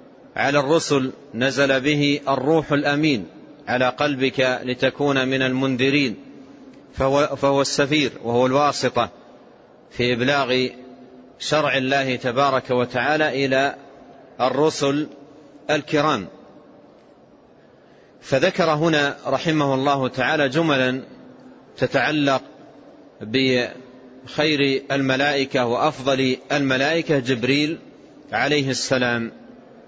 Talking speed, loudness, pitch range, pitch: 80 wpm, -20 LUFS, 130-145 Hz, 135 Hz